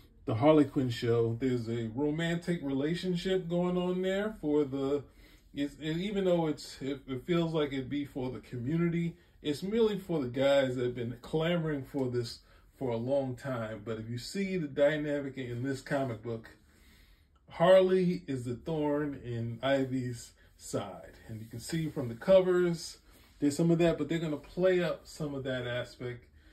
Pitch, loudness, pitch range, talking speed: 140 Hz, -32 LUFS, 120-165 Hz, 180 wpm